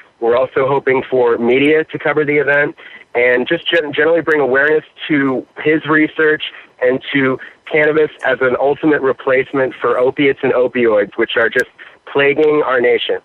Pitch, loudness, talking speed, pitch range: 145 Hz, -14 LUFS, 155 wpm, 130-155 Hz